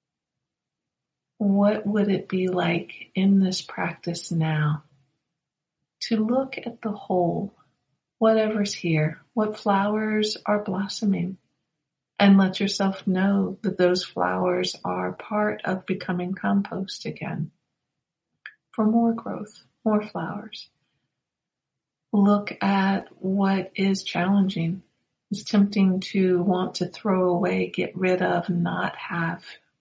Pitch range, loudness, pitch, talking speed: 175-205 Hz, -24 LUFS, 195 Hz, 110 wpm